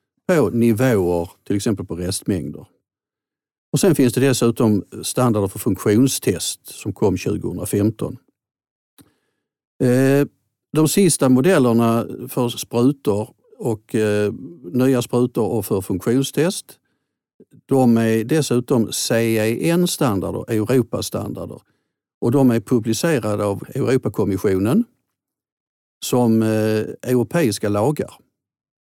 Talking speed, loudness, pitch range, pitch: 85 wpm, -19 LUFS, 110-135 Hz, 120 Hz